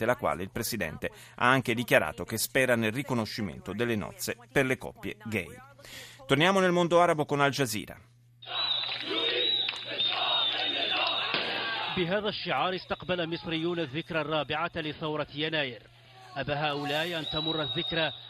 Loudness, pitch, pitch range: -29 LUFS, 145 Hz, 120-165 Hz